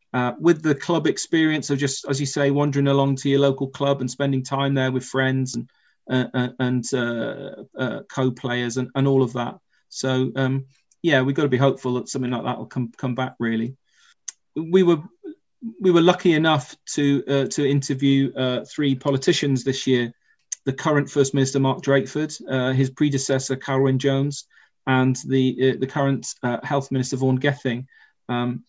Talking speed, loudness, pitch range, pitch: 180 wpm, -22 LUFS, 130-140 Hz, 135 Hz